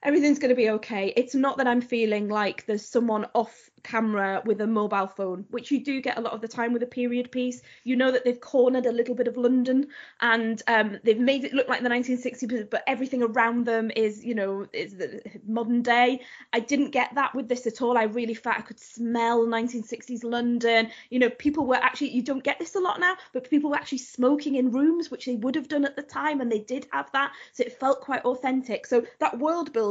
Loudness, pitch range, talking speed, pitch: -26 LUFS, 230-265 Hz, 235 wpm, 245 Hz